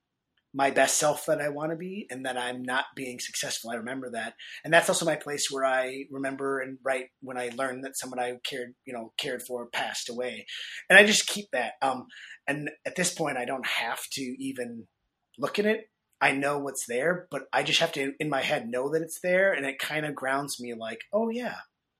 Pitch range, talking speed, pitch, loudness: 125-155 Hz, 225 wpm, 135 Hz, -28 LUFS